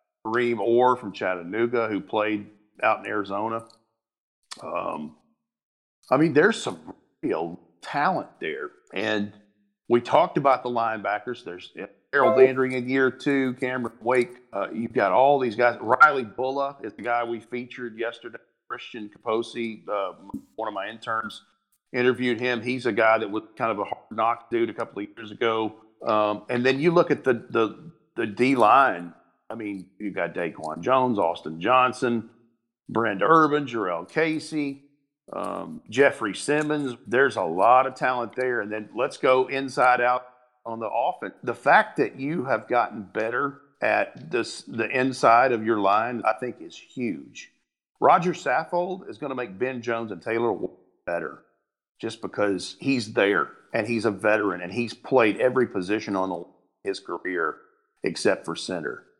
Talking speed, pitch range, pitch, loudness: 160 wpm, 110-135 Hz, 120 Hz, -24 LUFS